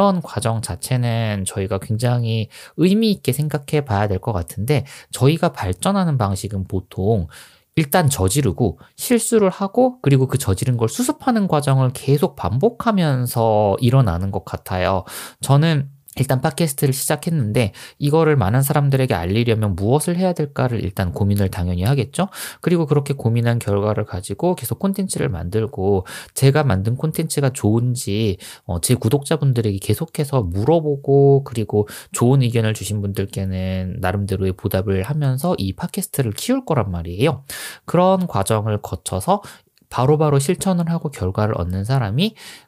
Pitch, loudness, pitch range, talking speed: 125 Hz, -19 LUFS, 100-155 Hz, 345 characters per minute